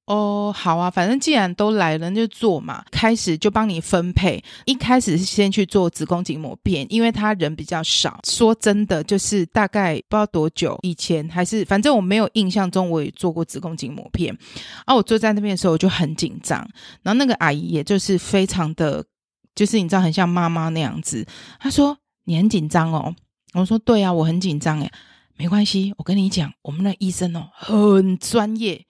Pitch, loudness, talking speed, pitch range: 190 Hz, -20 LUFS, 295 characters per minute, 165-210 Hz